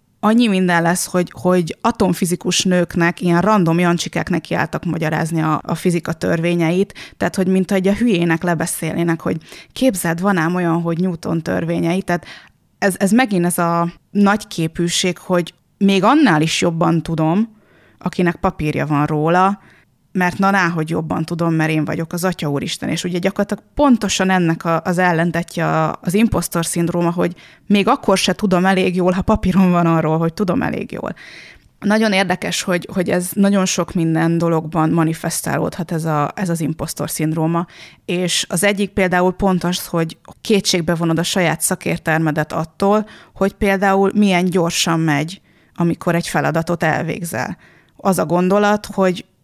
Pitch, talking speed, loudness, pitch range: 175 Hz, 155 wpm, -17 LUFS, 165-195 Hz